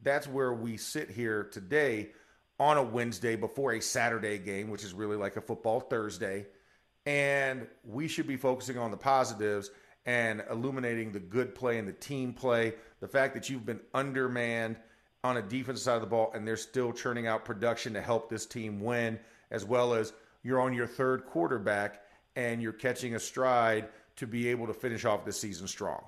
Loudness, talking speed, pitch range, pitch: -33 LUFS, 190 wpm, 110-130 Hz, 115 Hz